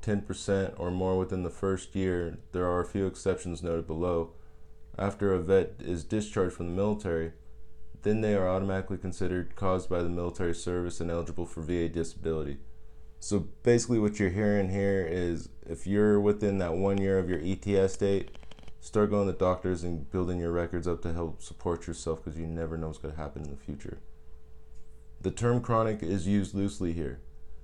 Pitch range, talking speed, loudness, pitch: 80-95 Hz, 185 wpm, -31 LUFS, 90 Hz